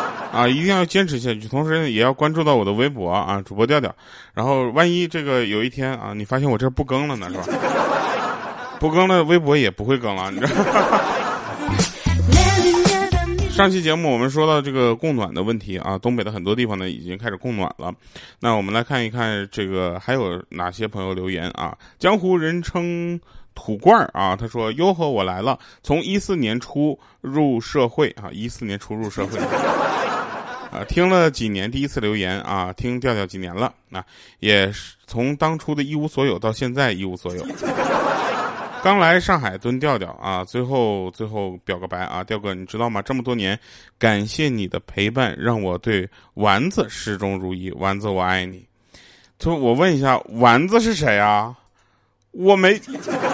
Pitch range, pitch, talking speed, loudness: 100-145 Hz, 120 Hz, 260 characters per minute, -20 LUFS